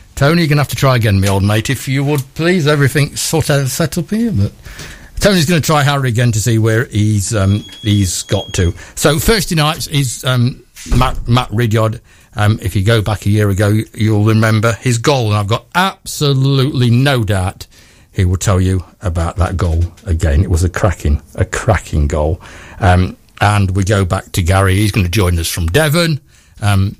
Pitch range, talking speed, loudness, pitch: 95-135 Hz, 205 wpm, -14 LUFS, 110 Hz